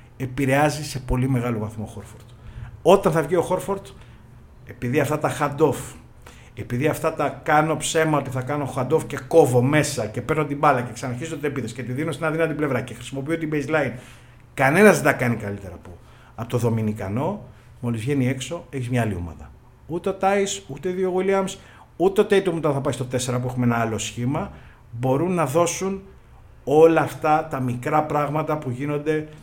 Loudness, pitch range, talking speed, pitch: -22 LUFS, 120-155 Hz, 190 wpm, 135 Hz